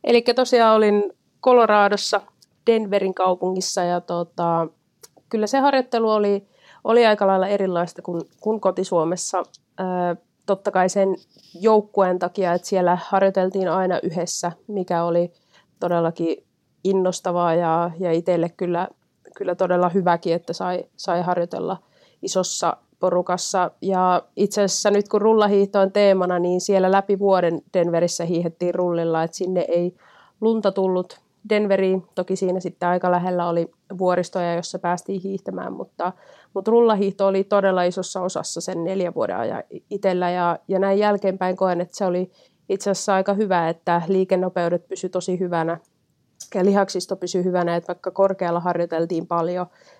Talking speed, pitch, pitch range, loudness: 140 wpm, 185 Hz, 175-195 Hz, -21 LUFS